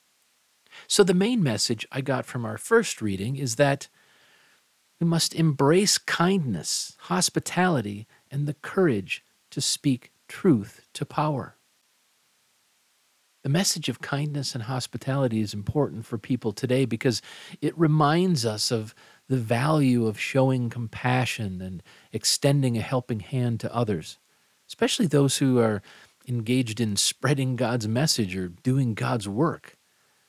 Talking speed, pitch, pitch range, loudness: 130 wpm, 130 Hz, 115-150 Hz, -25 LUFS